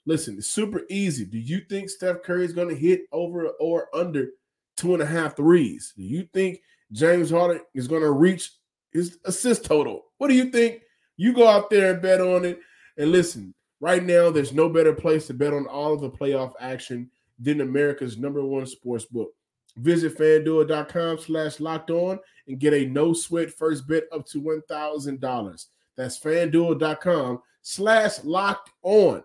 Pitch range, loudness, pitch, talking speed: 145-180 Hz, -23 LUFS, 160 Hz, 180 wpm